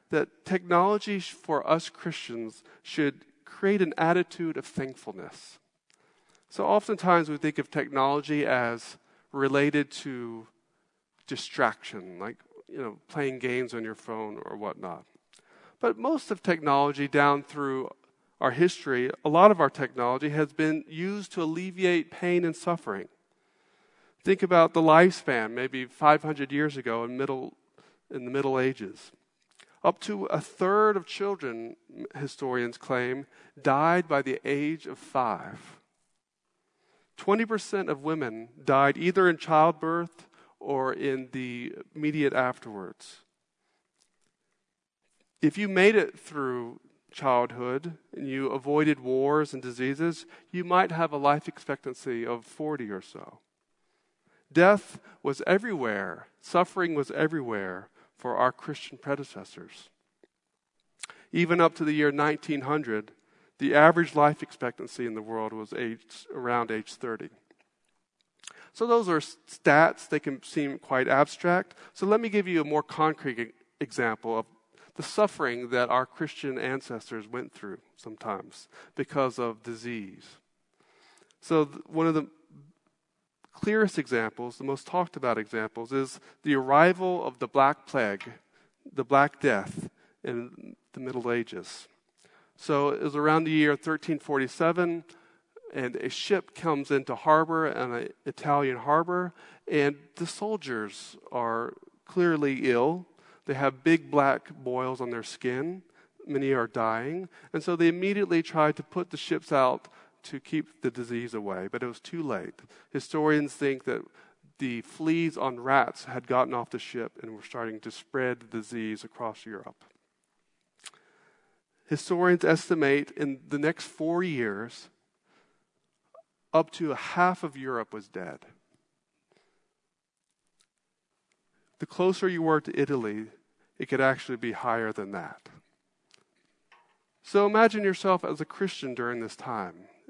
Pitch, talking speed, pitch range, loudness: 150 Hz, 135 wpm, 130-170 Hz, -28 LUFS